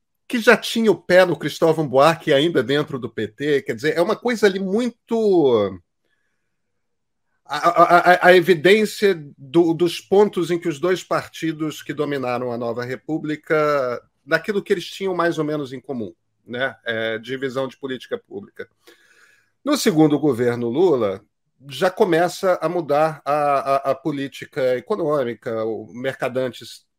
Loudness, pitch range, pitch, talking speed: -20 LUFS, 135-185 Hz, 155 Hz, 150 wpm